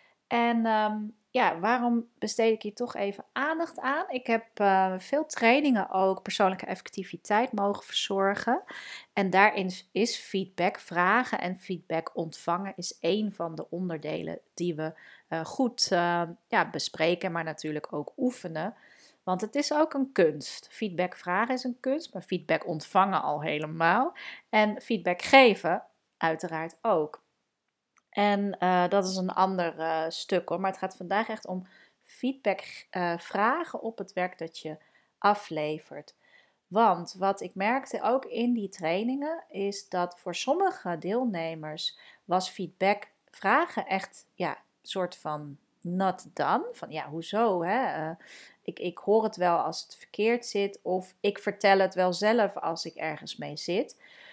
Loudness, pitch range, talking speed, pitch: -29 LUFS, 175-225 Hz, 150 wpm, 195 Hz